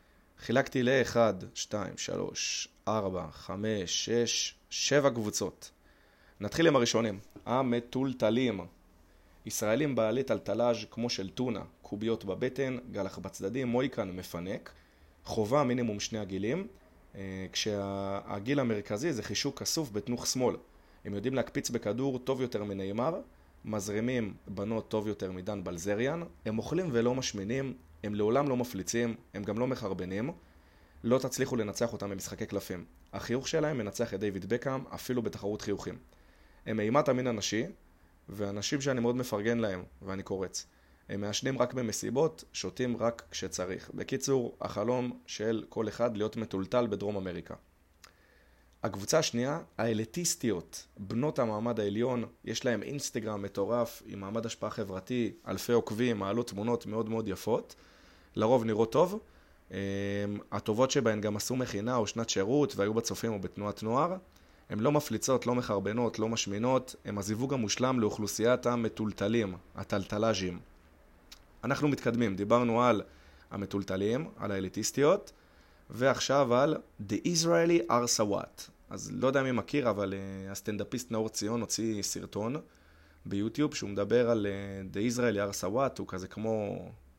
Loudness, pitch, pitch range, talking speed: -32 LUFS, 110 Hz, 100-120 Hz, 130 wpm